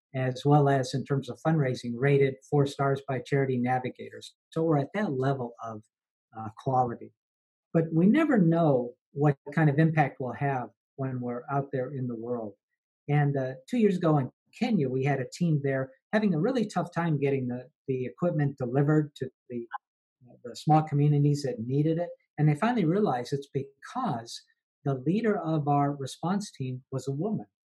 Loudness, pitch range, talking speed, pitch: -28 LUFS, 130-160 Hz, 180 wpm, 140 Hz